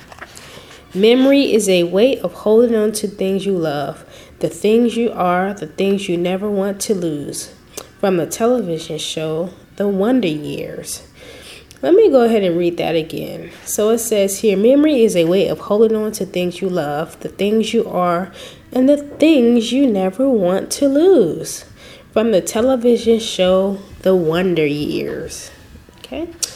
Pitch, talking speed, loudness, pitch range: 200 Hz, 165 wpm, -16 LUFS, 175-230 Hz